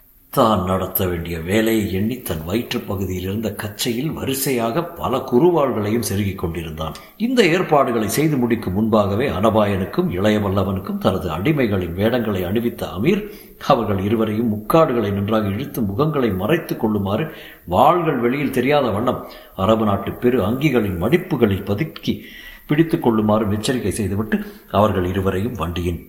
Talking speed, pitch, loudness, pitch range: 120 wpm, 110 Hz, -19 LUFS, 95-125 Hz